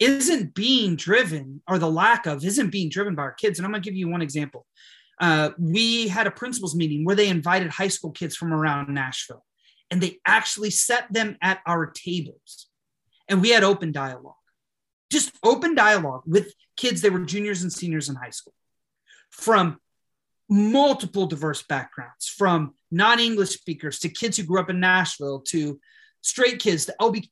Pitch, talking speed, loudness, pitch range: 185 Hz, 180 wpm, -22 LUFS, 160-215 Hz